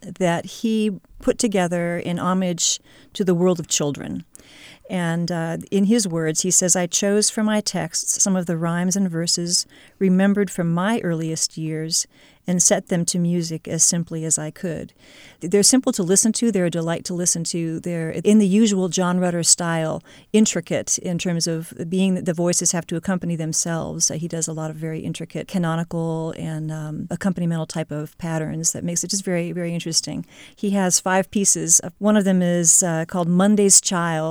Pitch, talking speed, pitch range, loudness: 175 Hz, 185 wpm, 165-190 Hz, -20 LUFS